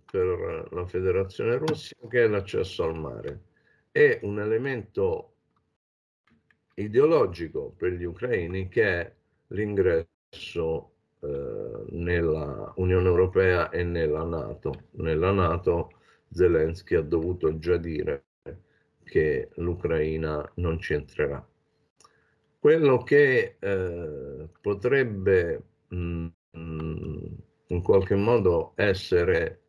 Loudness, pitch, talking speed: -26 LUFS, 100 Hz, 95 wpm